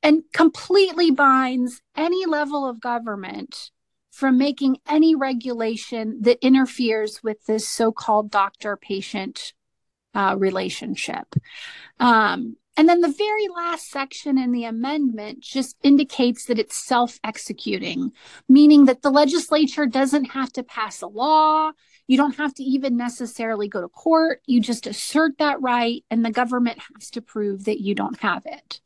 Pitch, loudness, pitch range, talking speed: 260 Hz, -20 LUFS, 230-295 Hz, 150 wpm